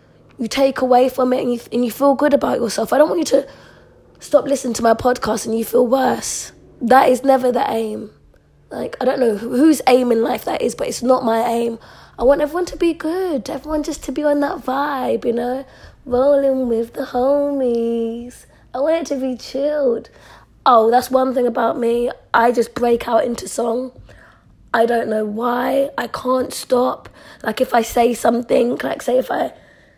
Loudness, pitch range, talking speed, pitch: -18 LUFS, 235-275 Hz, 200 wpm, 250 Hz